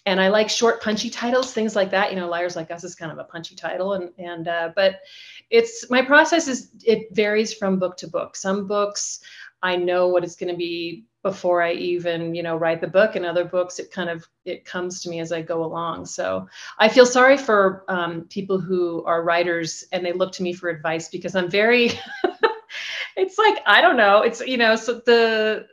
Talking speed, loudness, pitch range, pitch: 220 wpm, -21 LUFS, 175-220 Hz, 185 Hz